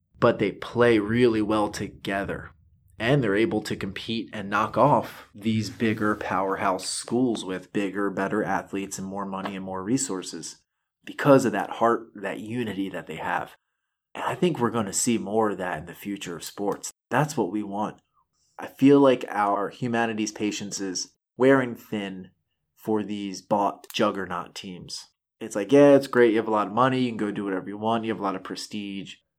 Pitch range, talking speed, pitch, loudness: 100-115 Hz, 190 wpm, 105 Hz, -25 LUFS